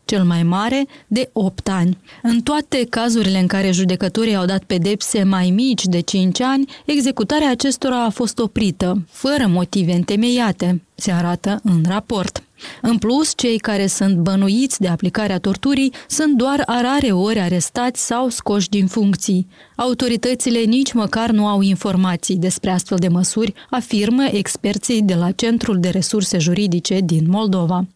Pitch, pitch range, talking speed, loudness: 205 Hz, 185-240 Hz, 150 wpm, -17 LUFS